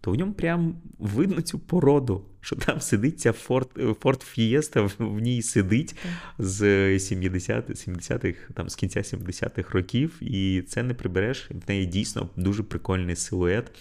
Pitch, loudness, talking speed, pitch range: 115 Hz, -26 LUFS, 150 wpm, 95-135 Hz